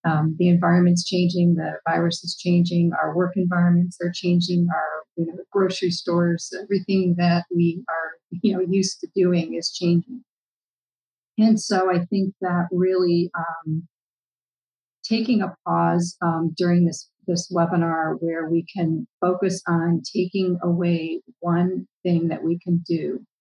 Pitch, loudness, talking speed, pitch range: 175 Hz, -22 LUFS, 150 wpm, 170-180 Hz